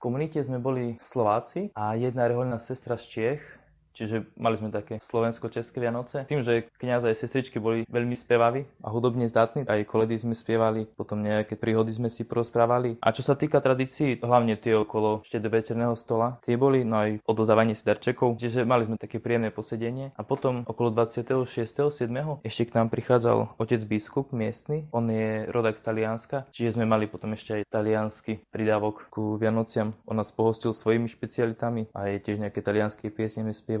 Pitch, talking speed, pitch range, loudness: 115 Hz, 180 wpm, 110-120 Hz, -27 LUFS